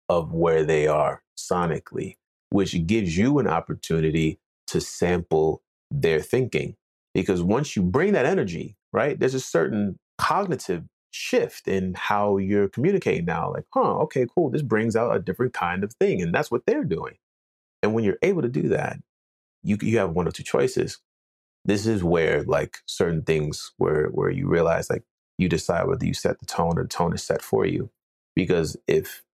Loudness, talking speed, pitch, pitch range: -24 LUFS, 180 wpm, 90 Hz, 80-110 Hz